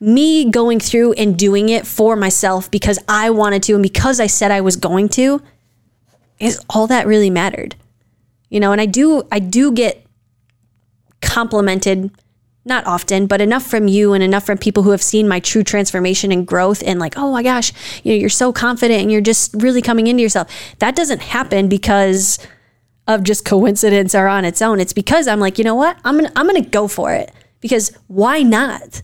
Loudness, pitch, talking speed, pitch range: -14 LUFS, 205 Hz, 200 wpm, 190-230 Hz